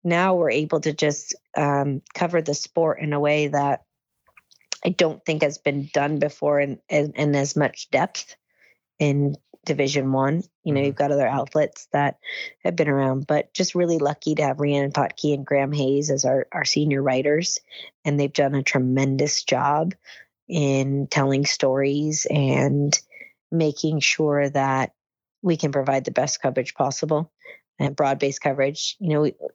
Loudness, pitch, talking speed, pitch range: -22 LUFS, 145 Hz, 170 wpm, 140-155 Hz